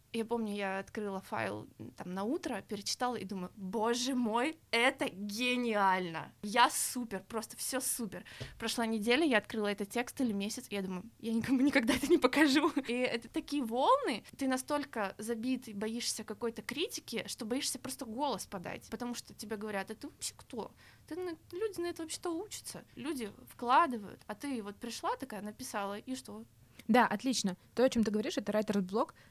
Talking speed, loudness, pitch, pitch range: 175 wpm, -34 LUFS, 235 Hz, 210-275 Hz